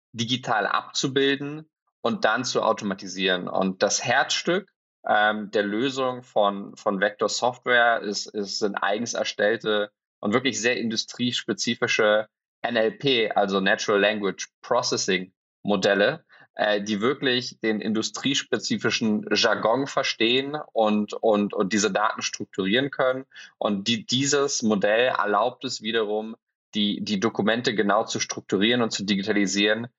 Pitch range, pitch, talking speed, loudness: 105-125 Hz, 110 Hz, 120 wpm, -24 LUFS